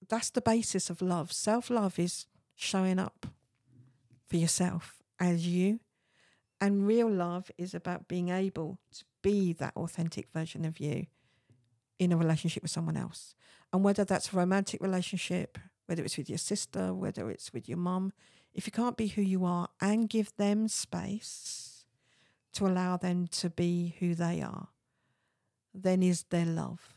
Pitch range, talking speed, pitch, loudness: 170-195 Hz, 160 wpm, 180 Hz, -32 LUFS